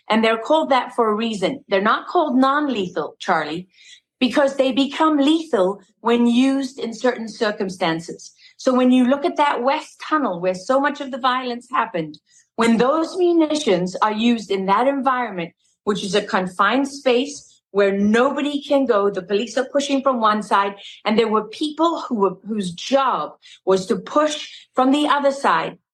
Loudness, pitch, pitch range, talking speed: -20 LUFS, 245 Hz, 200-275 Hz, 175 wpm